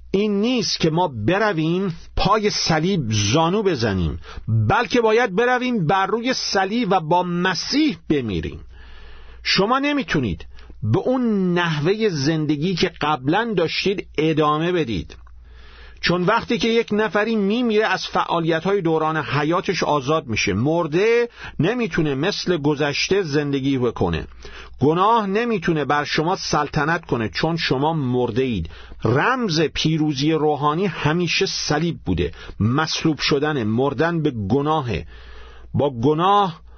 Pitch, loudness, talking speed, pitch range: 160 Hz, -20 LUFS, 115 wpm, 135-195 Hz